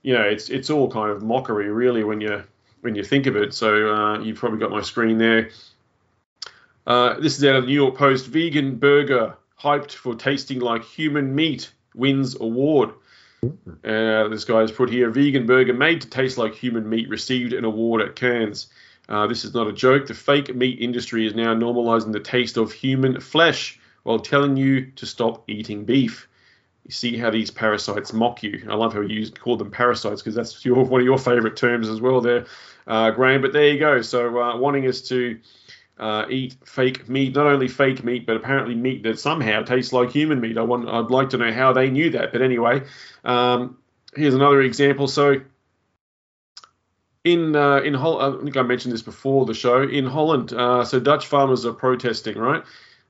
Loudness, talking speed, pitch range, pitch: -20 LUFS, 200 wpm, 115-135 Hz, 125 Hz